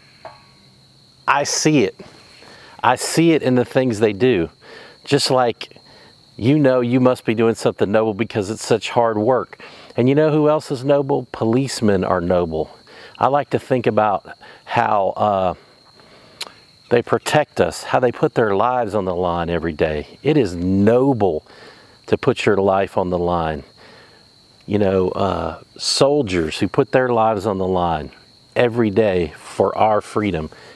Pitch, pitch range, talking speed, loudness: 110 Hz, 95-130 Hz, 160 wpm, -18 LUFS